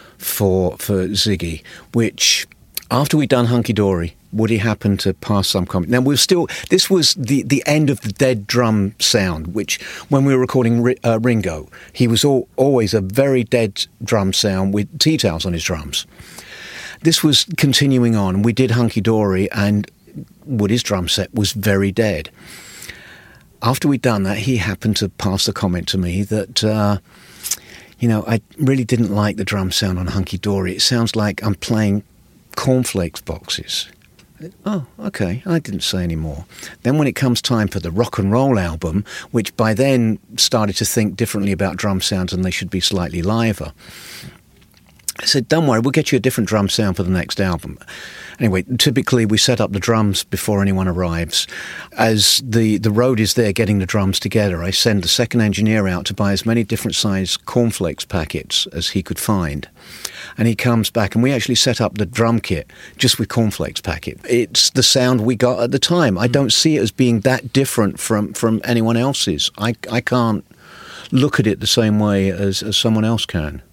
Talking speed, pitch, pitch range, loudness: 190 wpm, 110 Hz, 100-125 Hz, -17 LUFS